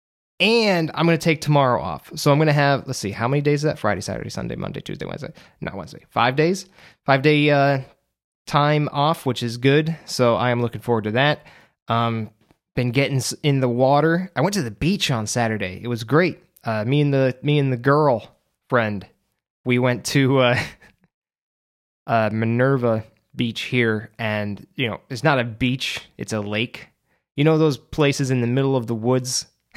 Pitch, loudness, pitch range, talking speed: 130 Hz, -21 LUFS, 115-150 Hz, 195 wpm